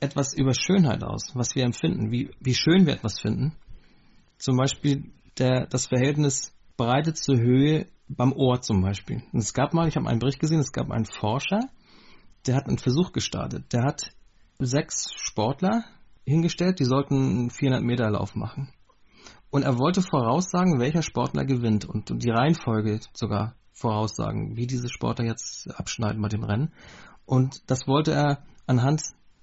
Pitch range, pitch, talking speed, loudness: 115-145 Hz, 130 Hz, 165 wpm, -25 LUFS